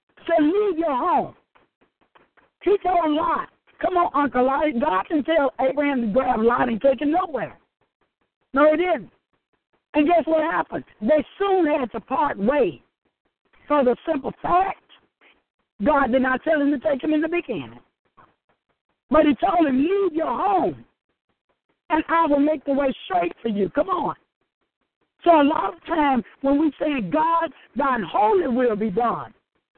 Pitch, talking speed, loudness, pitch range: 305 Hz, 170 wpm, -21 LUFS, 275-335 Hz